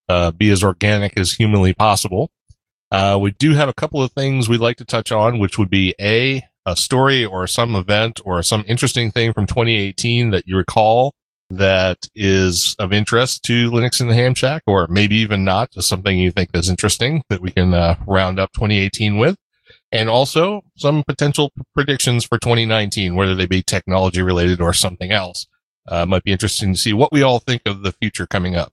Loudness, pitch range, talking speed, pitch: -16 LUFS, 95-120 Hz, 205 wpm, 105 Hz